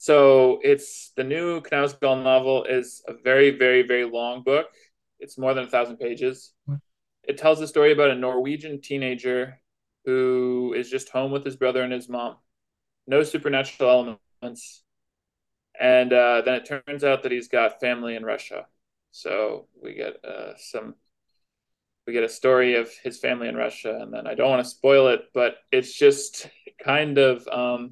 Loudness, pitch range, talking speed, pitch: -22 LUFS, 125-145 Hz, 170 wpm, 130 Hz